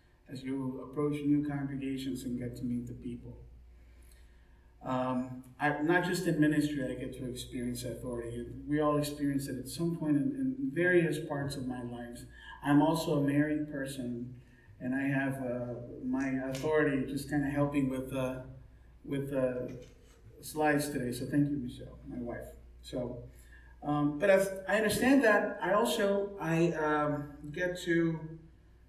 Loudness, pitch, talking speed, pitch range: -32 LUFS, 135 Hz, 160 wpm, 125-150 Hz